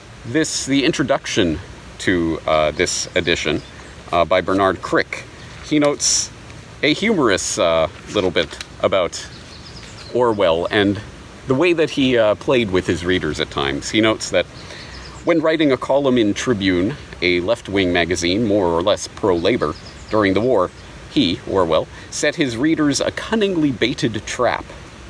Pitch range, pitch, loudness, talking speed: 90-145 Hz, 105 Hz, -18 LUFS, 145 wpm